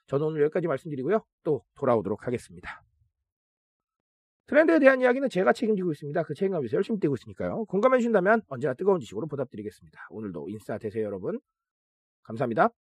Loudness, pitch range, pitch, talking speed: -26 LUFS, 135-225 Hz, 180 Hz, 475 characters per minute